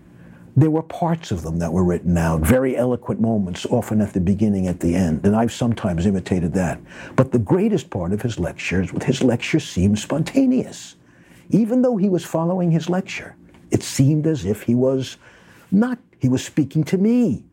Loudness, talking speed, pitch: -20 LUFS, 190 wpm, 120 Hz